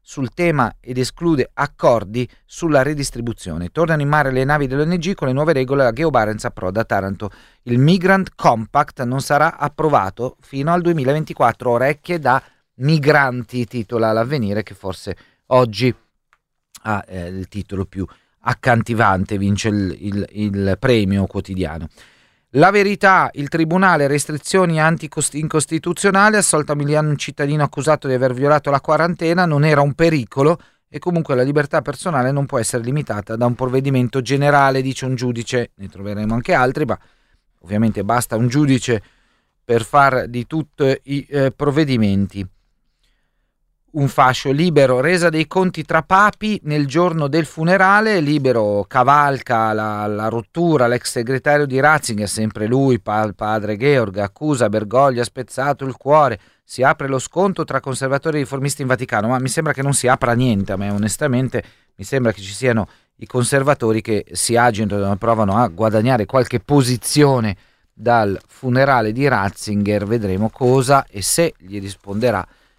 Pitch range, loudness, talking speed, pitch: 110-150 Hz, -17 LUFS, 150 wpm, 130 Hz